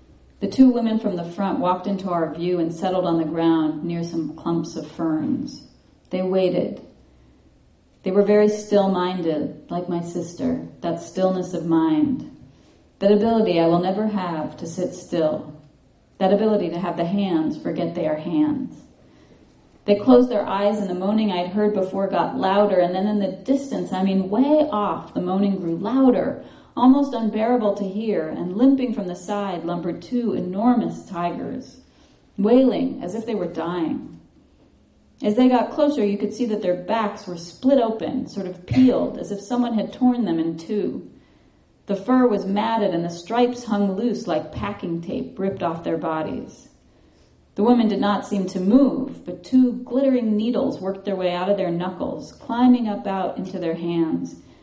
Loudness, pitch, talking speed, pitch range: -22 LUFS, 195 Hz, 175 wpm, 170-230 Hz